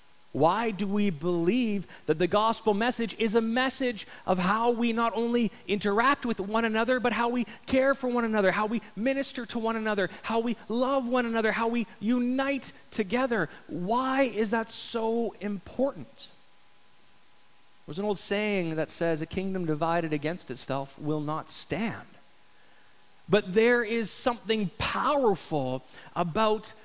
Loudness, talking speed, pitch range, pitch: -28 LUFS, 150 wpm, 185-235 Hz, 220 Hz